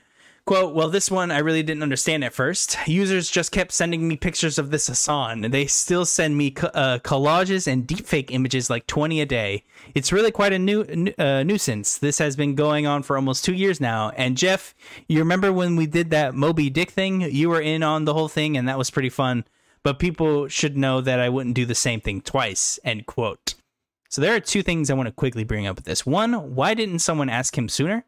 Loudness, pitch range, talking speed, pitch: -22 LUFS, 130-175 Hz, 230 wpm, 150 Hz